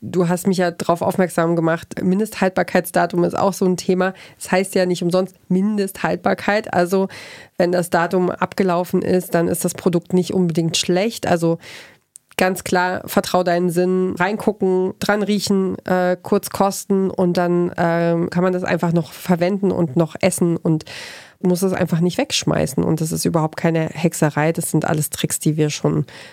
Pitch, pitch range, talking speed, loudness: 180 Hz, 170-190 Hz, 175 wpm, -19 LUFS